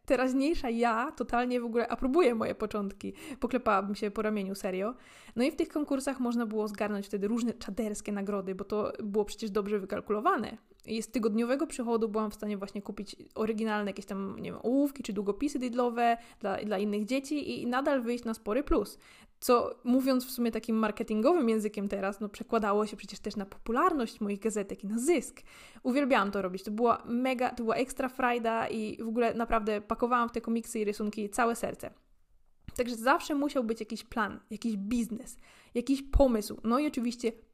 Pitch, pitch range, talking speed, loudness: 230 Hz, 210-250 Hz, 180 wpm, -31 LUFS